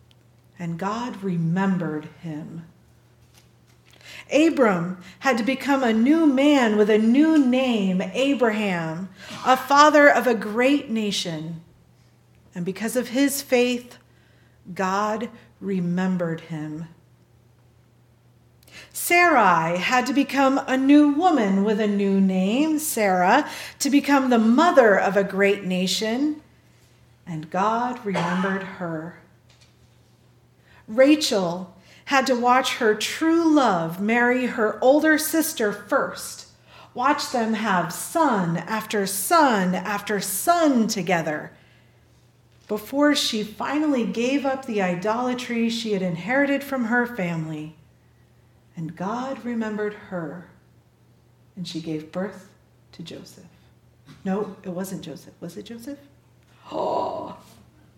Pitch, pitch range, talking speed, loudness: 210 Hz, 175-255 Hz, 110 wpm, -21 LUFS